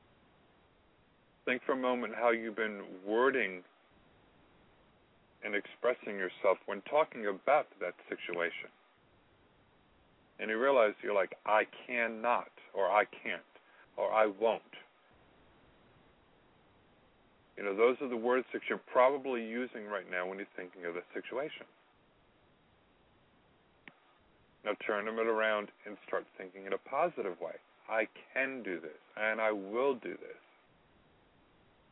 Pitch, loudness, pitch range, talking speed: 110 Hz, -34 LUFS, 100-120 Hz, 125 wpm